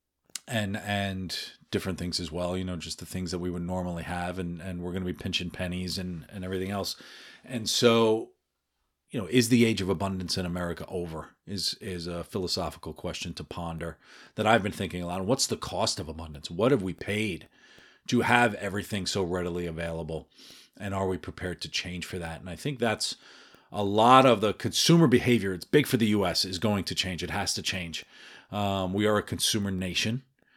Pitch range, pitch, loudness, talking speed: 85-105 Hz, 95 Hz, -28 LUFS, 210 wpm